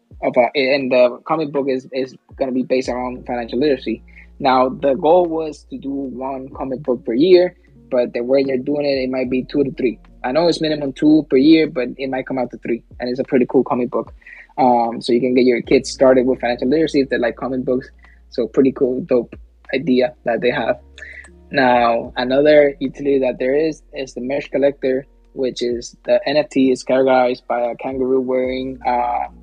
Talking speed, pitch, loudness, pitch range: 210 wpm, 130 Hz, -18 LUFS, 125-140 Hz